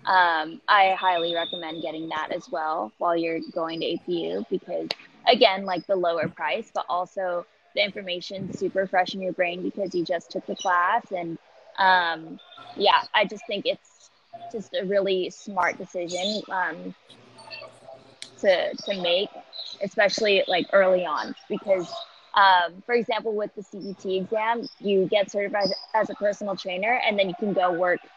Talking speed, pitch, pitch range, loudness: 160 wpm, 190 Hz, 175-205 Hz, -25 LUFS